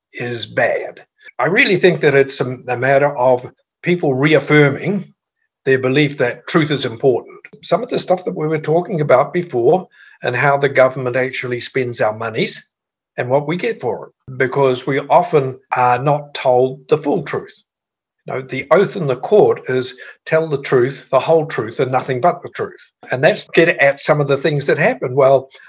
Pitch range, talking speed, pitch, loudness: 130-160 Hz, 185 wpm, 140 Hz, -16 LUFS